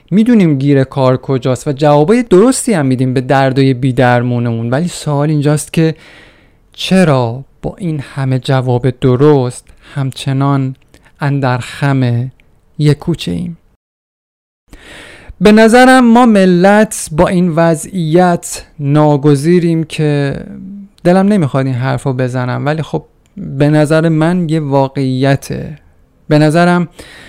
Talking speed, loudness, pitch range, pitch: 115 wpm, -11 LUFS, 130-175 Hz, 145 Hz